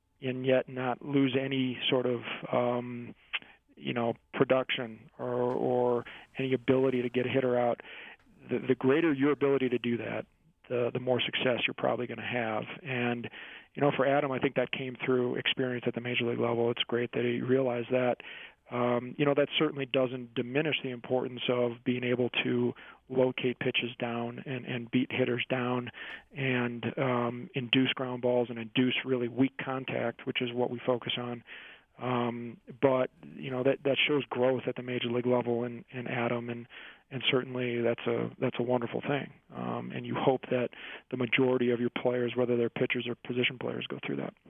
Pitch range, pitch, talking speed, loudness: 120-130 Hz, 125 Hz, 185 wpm, -31 LUFS